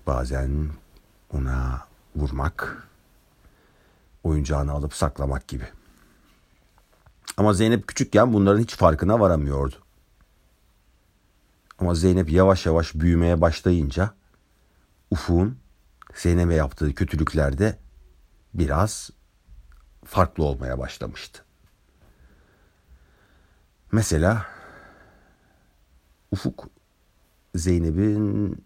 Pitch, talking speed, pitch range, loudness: 80 Hz, 65 wpm, 70-95 Hz, -23 LUFS